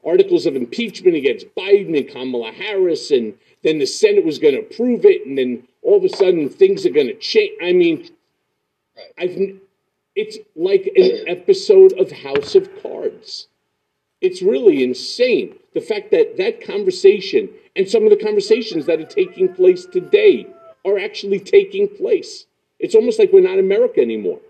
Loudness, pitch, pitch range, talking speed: -16 LUFS, 395 Hz, 365-425 Hz, 170 wpm